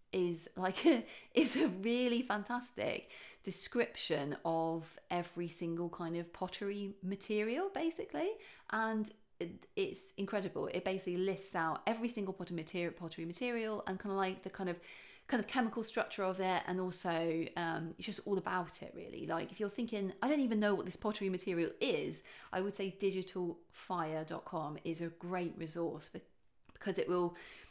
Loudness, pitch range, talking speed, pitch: -38 LUFS, 170-220 Hz, 165 wpm, 190 Hz